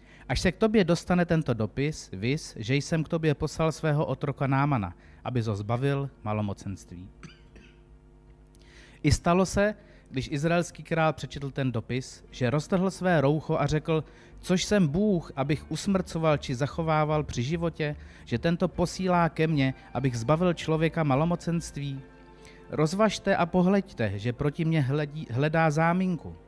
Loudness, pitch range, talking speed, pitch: -27 LUFS, 130-170 Hz, 145 wpm, 155 Hz